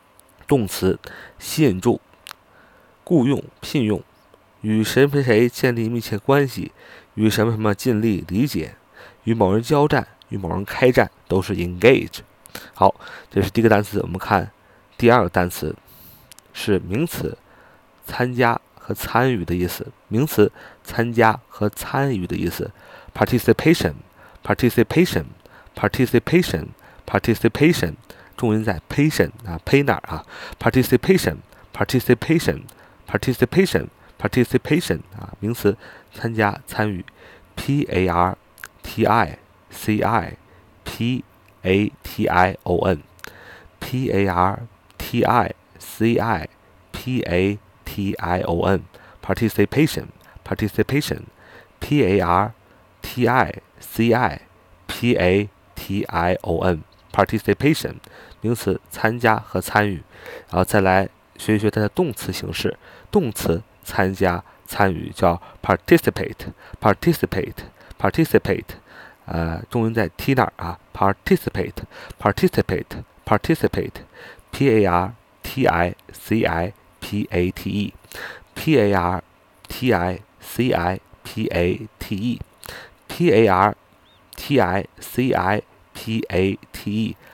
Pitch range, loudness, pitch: 95-115 Hz, -20 LUFS, 105 Hz